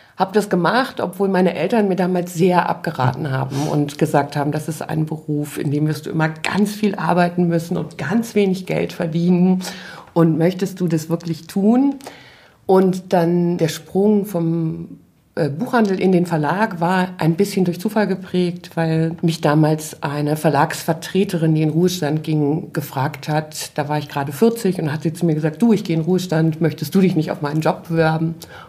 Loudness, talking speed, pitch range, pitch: -19 LUFS, 185 wpm, 155-185 Hz, 170 Hz